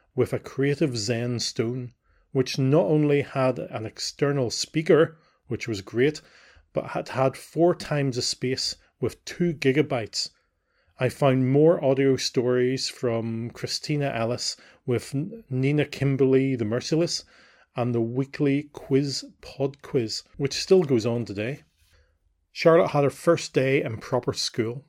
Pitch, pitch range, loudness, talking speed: 135 Hz, 120-145 Hz, -25 LUFS, 135 wpm